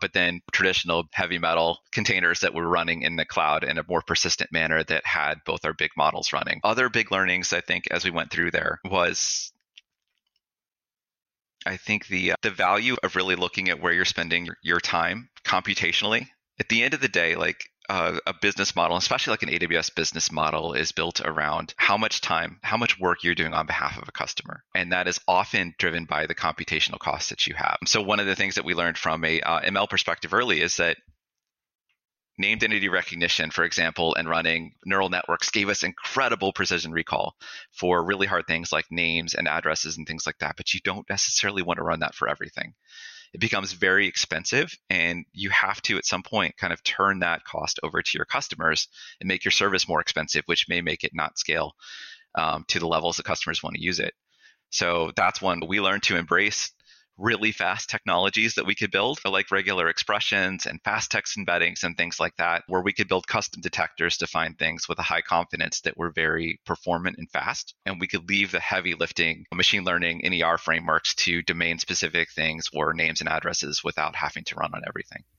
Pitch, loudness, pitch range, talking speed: 90 Hz, -24 LUFS, 85-95 Hz, 205 wpm